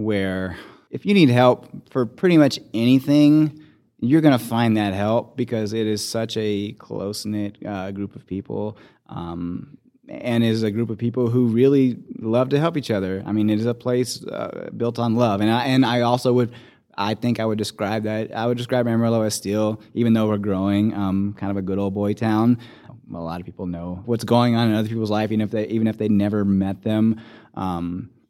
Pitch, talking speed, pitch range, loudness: 110 Hz, 215 wpm, 105-120 Hz, -21 LUFS